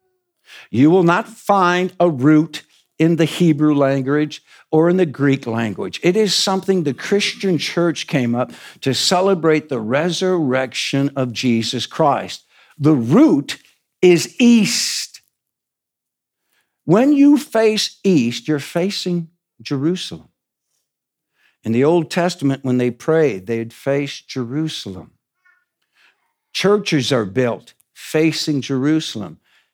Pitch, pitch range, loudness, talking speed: 160 Hz, 135-190 Hz, -17 LUFS, 115 wpm